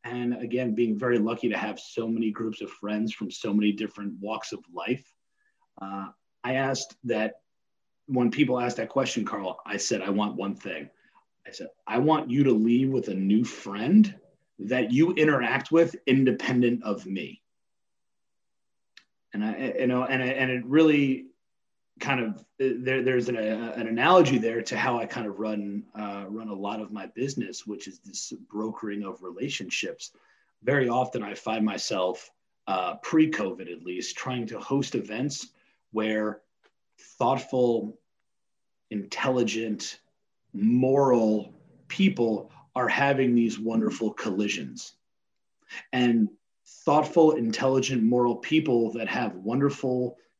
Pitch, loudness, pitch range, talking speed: 120 Hz, -27 LUFS, 110-135 Hz, 145 wpm